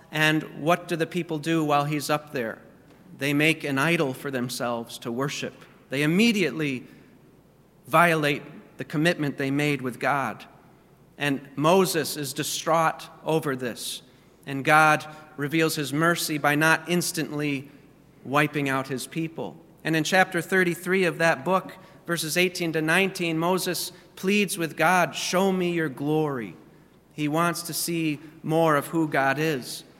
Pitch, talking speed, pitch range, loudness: 155 Hz, 145 wpm, 145-170 Hz, -25 LUFS